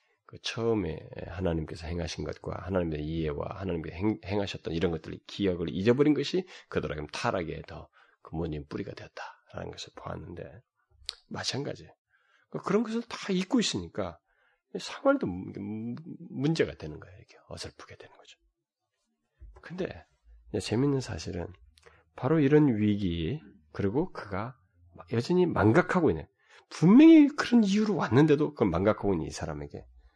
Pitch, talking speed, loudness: 100 Hz, 310 characters per minute, -28 LUFS